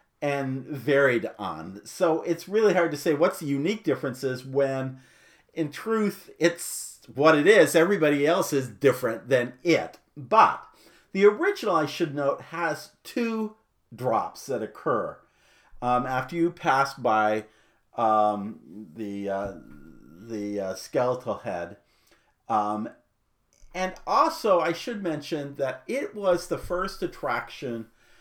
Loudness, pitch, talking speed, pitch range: -26 LUFS, 145 Hz, 130 wpm, 120-175 Hz